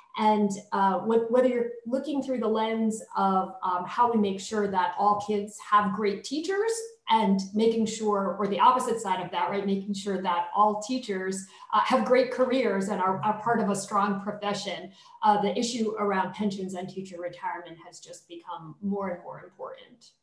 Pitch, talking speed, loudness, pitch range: 205 Hz, 185 wpm, -27 LUFS, 190-235 Hz